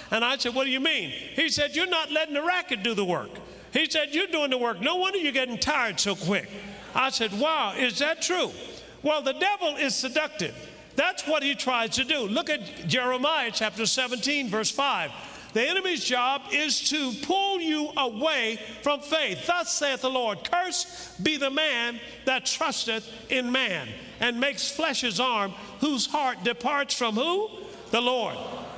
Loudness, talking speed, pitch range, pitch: -26 LUFS, 185 wpm, 240-310 Hz, 275 Hz